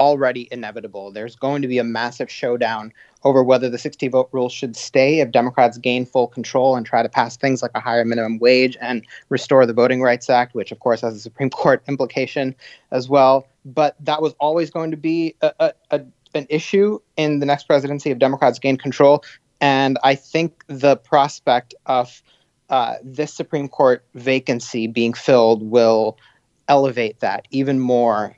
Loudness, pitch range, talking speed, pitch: -18 LUFS, 120-145 Hz, 180 wpm, 130 Hz